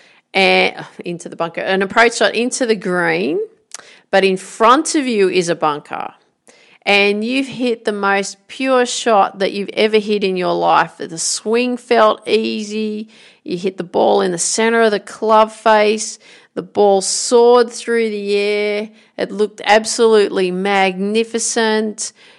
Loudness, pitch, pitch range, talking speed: -15 LUFS, 215 Hz, 195-230 Hz, 155 wpm